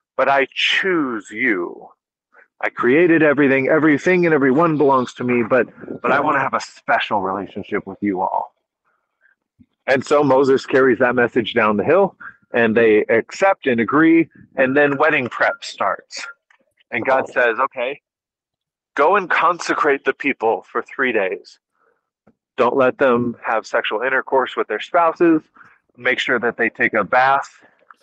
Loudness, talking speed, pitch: -17 LUFS, 155 wpm, 155 Hz